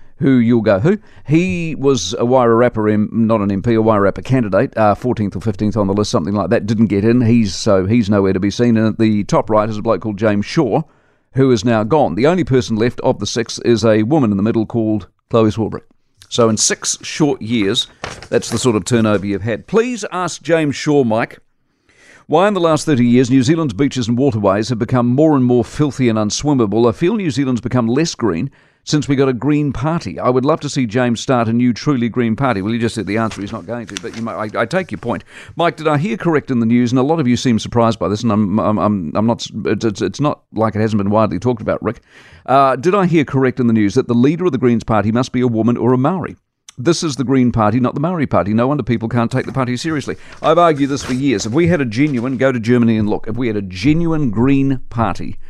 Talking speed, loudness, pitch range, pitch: 260 wpm, -15 LUFS, 110-140 Hz, 120 Hz